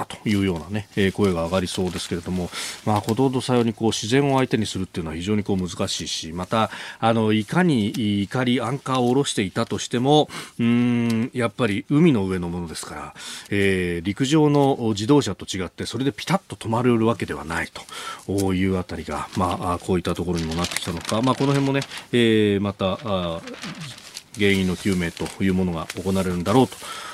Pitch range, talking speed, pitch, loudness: 95-120 Hz, 400 characters per minute, 105 Hz, -22 LUFS